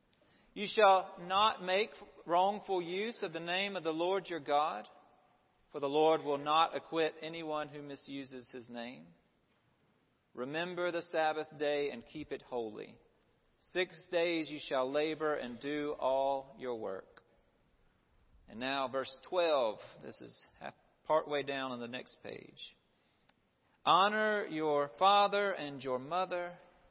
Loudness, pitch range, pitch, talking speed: -34 LUFS, 135-180 Hz, 155 Hz, 140 wpm